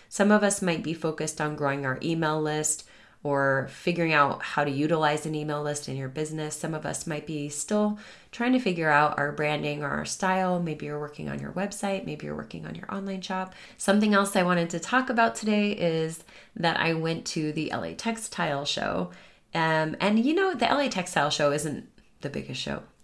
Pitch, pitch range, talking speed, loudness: 160 Hz, 150-195 Hz, 210 wpm, -27 LUFS